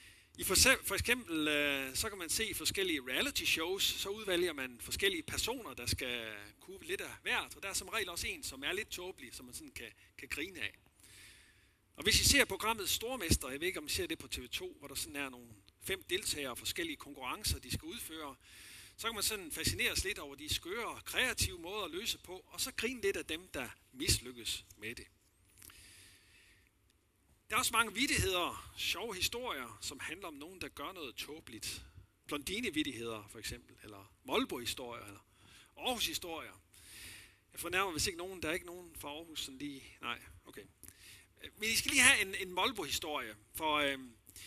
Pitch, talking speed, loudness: 130 Hz, 195 wpm, -35 LUFS